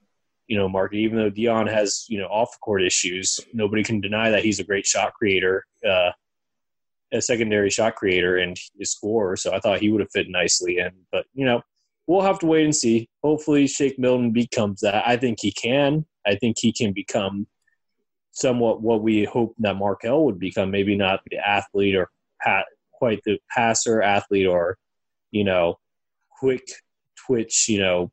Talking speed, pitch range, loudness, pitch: 185 wpm, 100-120 Hz, -22 LUFS, 110 Hz